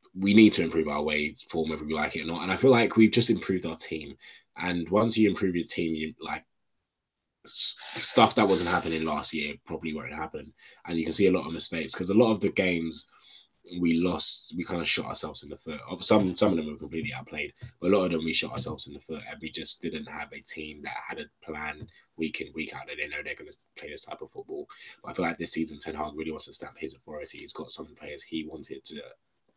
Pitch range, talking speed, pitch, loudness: 80-105 Hz, 260 wpm, 85 Hz, -28 LUFS